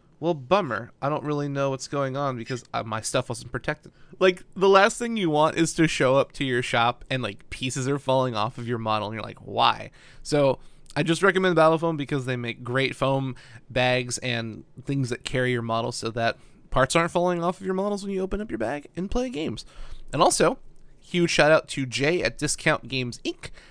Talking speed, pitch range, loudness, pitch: 220 wpm, 120-165 Hz, -25 LUFS, 135 Hz